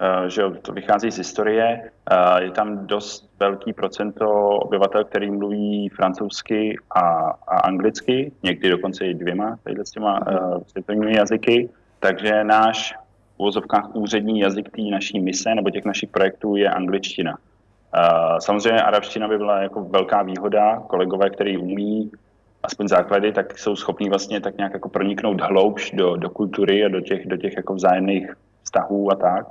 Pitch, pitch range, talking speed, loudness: 105 Hz, 100-105 Hz, 155 wpm, -21 LUFS